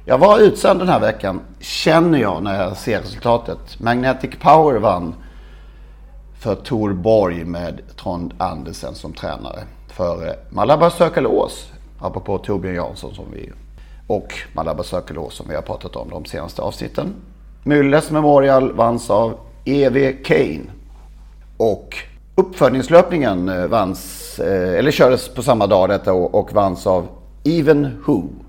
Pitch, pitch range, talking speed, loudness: 115 Hz, 90-145 Hz, 130 wpm, -17 LUFS